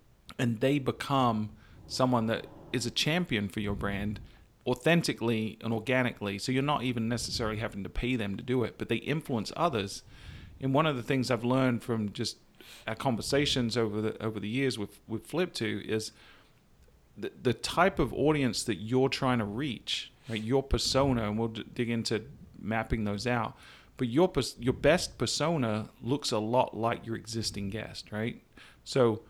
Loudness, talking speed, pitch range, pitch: -31 LUFS, 180 wpm, 110-130 Hz, 115 Hz